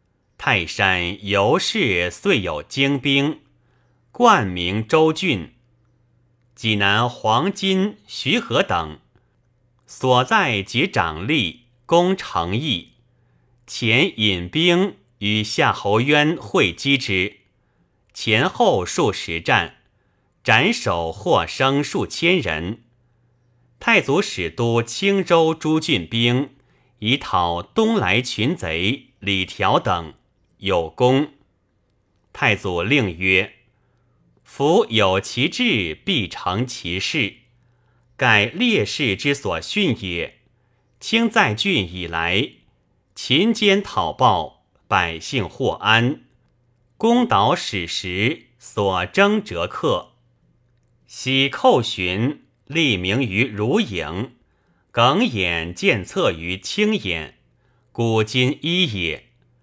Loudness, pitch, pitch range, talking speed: -19 LUFS, 120 Hz, 100-140 Hz, 130 characters per minute